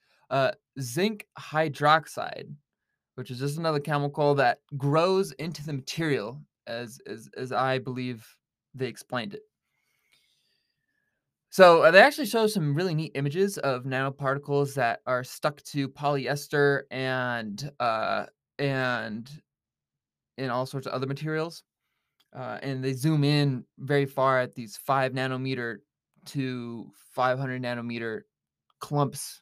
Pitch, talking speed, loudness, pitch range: 140 Hz, 125 wpm, -27 LUFS, 130-150 Hz